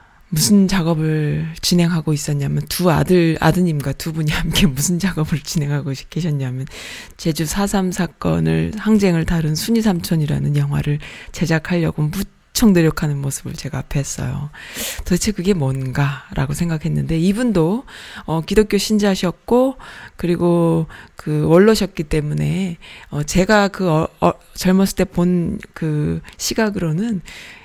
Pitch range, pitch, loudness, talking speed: 150-190 Hz, 165 Hz, -18 LUFS, 280 characters per minute